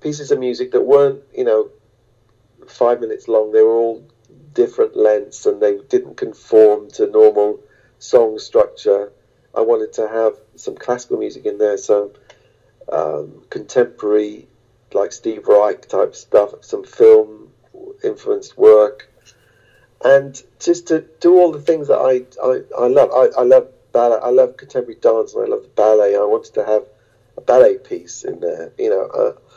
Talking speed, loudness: 165 wpm, -16 LUFS